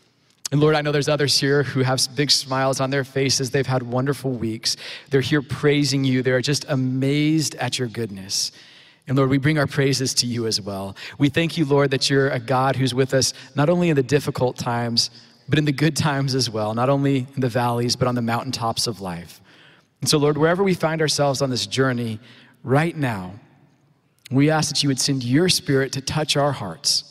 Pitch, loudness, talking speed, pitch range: 135 Hz, -21 LUFS, 215 wpm, 125-145 Hz